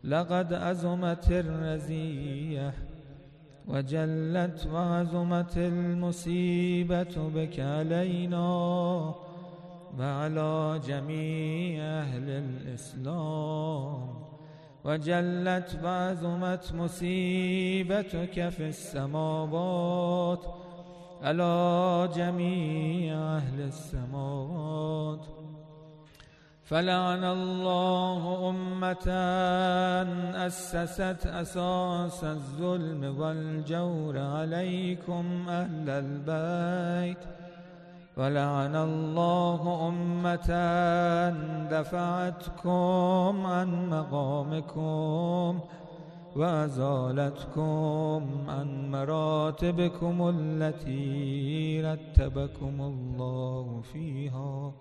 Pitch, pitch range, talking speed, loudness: 170 Hz, 155-175 Hz, 50 wpm, -30 LUFS